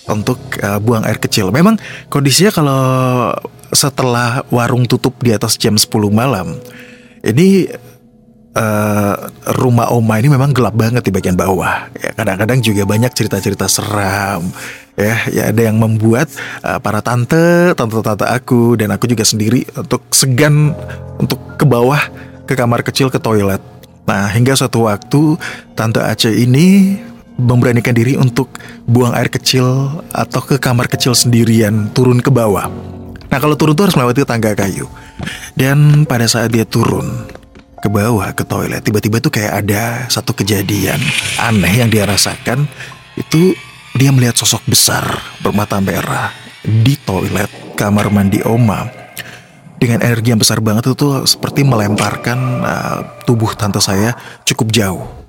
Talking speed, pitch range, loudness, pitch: 145 wpm, 110-135 Hz, -13 LUFS, 120 Hz